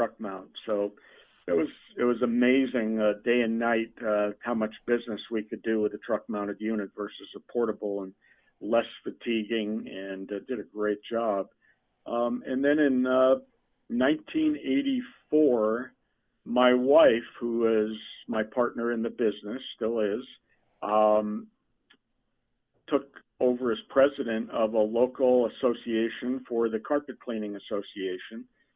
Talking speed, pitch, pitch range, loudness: 140 wpm, 115 Hz, 110-125 Hz, -28 LUFS